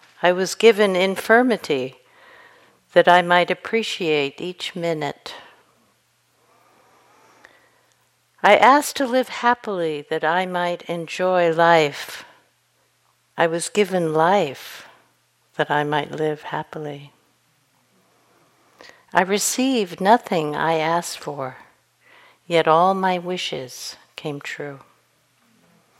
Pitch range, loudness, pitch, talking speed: 155-200 Hz, -20 LUFS, 175 Hz, 95 wpm